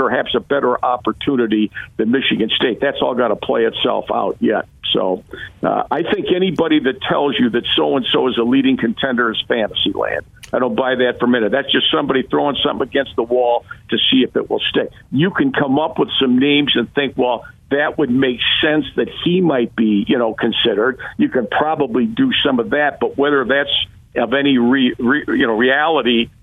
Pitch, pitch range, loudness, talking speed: 130 Hz, 120-140 Hz, -16 LUFS, 210 wpm